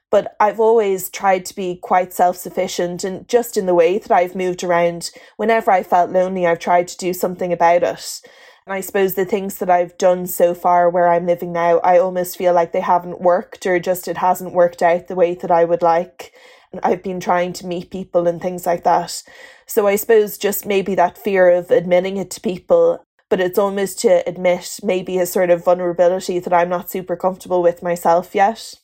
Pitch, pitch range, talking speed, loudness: 180 Hz, 175-195 Hz, 215 wpm, -17 LUFS